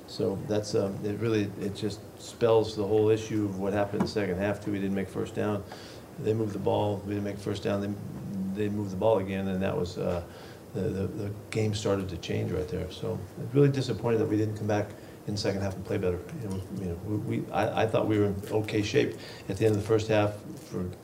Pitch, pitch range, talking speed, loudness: 105 Hz, 100-110 Hz, 255 wpm, -30 LUFS